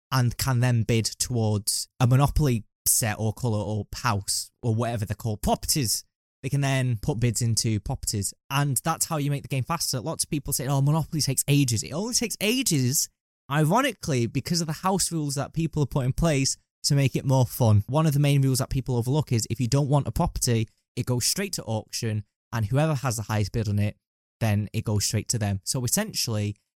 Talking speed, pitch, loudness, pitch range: 215 wpm, 130 Hz, -25 LUFS, 110-145 Hz